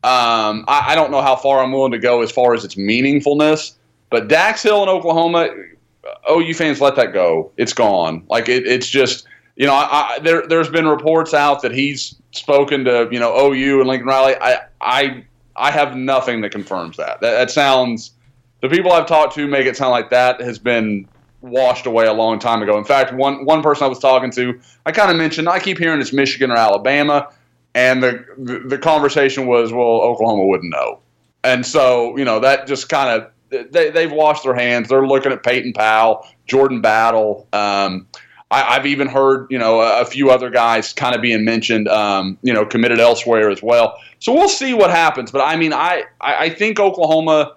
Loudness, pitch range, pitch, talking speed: -15 LUFS, 120-145 Hz, 130 Hz, 210 wpm